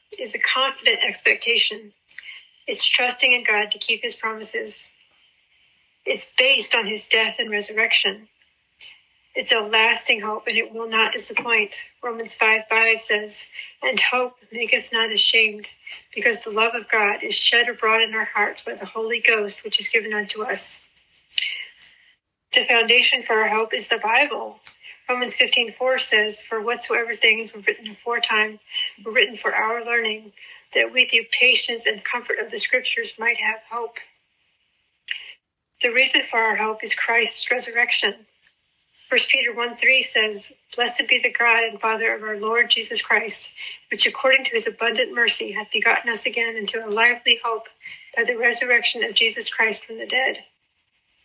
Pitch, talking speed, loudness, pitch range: 230 Hz, 165 wpm, -19 LUFS, 220-255 Hz